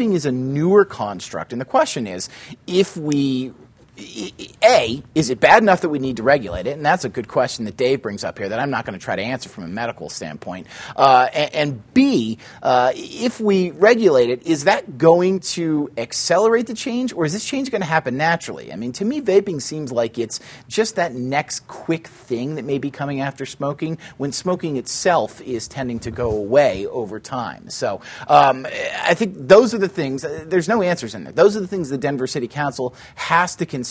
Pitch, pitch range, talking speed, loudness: 150 Hz, 130-185 Hz, 215 wpm, -19 LUFS